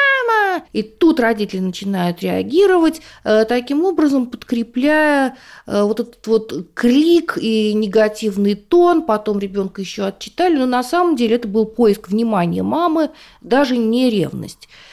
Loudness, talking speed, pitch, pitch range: -17 LUFS, 125 wpm, 240 Hz, 215-310 Hz